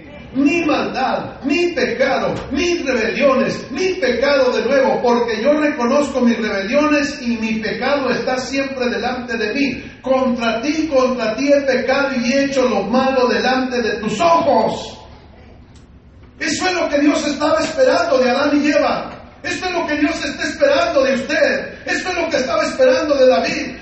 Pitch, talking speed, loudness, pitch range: 270 Hz, 165 wpm, -17 LUFS, 250-295 Hz